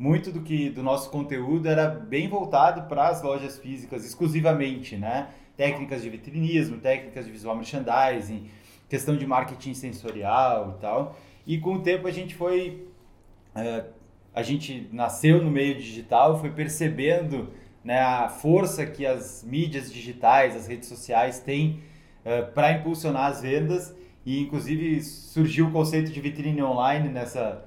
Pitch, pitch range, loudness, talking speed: 140 Hz, 125-155 Hz, -26 LUFS, 150 wpm